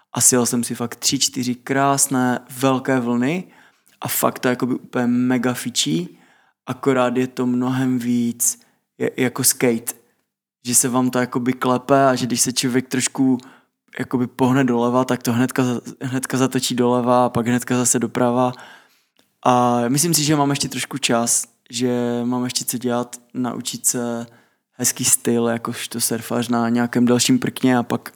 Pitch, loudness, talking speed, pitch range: 125 Hz, -19 LUFS, 170 wpm, 120-130 Hz